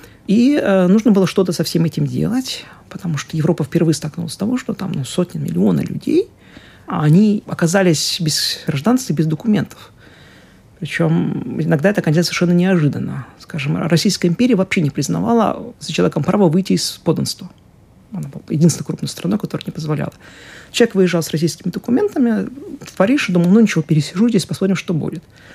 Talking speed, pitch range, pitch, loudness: 170 wpm, 160-205 Hz, 180 Hz, -17 LUFS